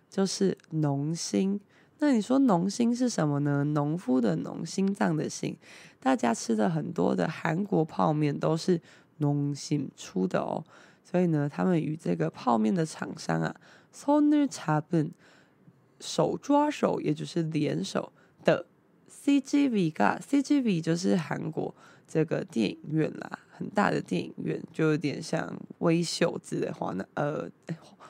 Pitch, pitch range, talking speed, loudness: 170 Hz, 150-205 Hz, 215 characters per minute, -29 LUFS